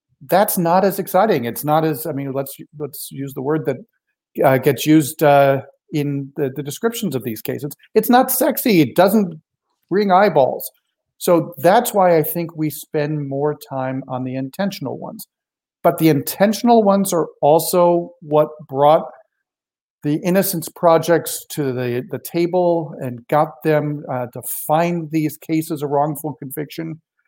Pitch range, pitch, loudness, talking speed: 140-175 Hz, 155 Hz, -18 LUFS, 160 wpm